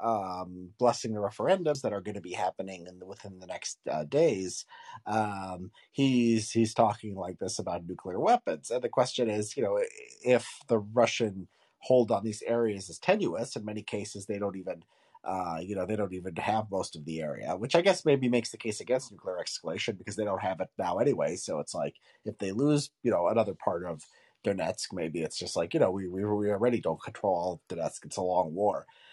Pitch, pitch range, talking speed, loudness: 105 Hz, 95-120 Hz, 215 wpm, -31 LUFS